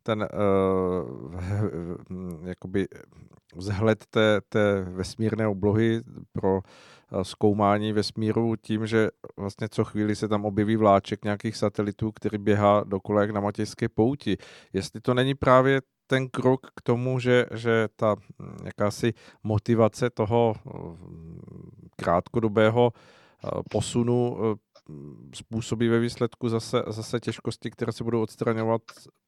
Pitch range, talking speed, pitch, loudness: 100-115 Hz, 115 wpm, 110 Hz, -26 LUFS